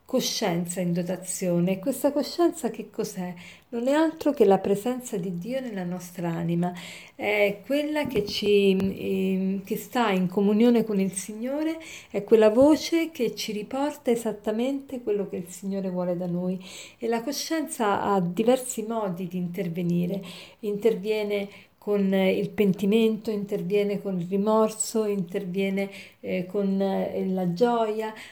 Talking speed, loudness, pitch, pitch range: 140 wpm, -26 LUFS, 205 Hz, 190-230 Hz